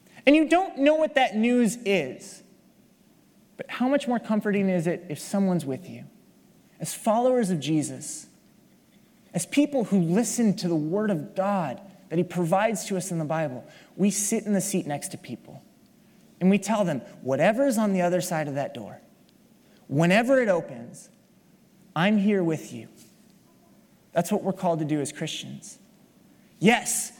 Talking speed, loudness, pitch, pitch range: 170 wpm, -25 LUFS, 200 Hz, 175-225 Hz